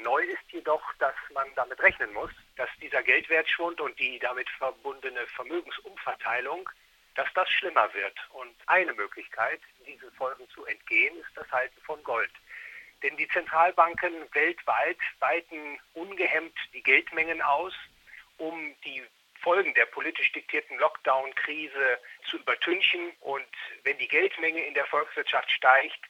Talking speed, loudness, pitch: 135 wpm, -27 LUFS, 170 Hz